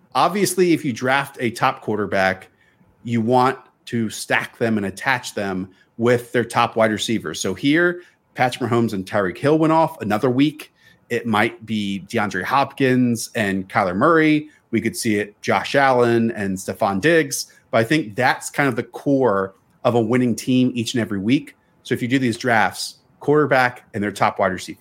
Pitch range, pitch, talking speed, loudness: 110-135 Hz, 120 Hz, 185 wpm, -20 LUFS